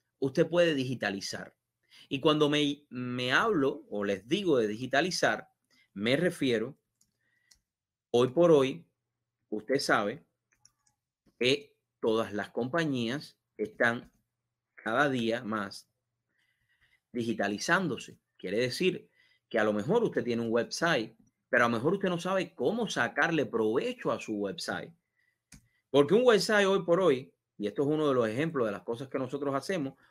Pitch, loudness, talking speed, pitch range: 125 Hz, -29 LUFS, 140 wpm, 115-150 Hz